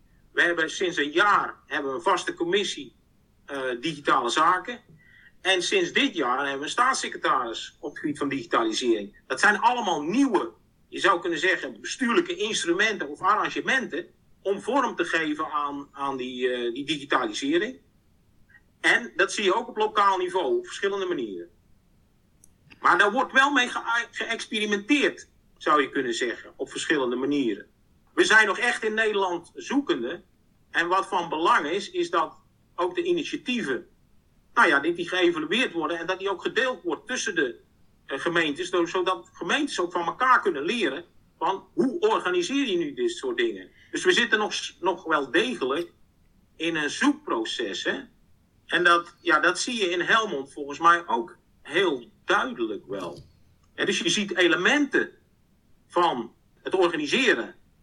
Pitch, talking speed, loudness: 265 Hz, 160 wpm, -25 LUFS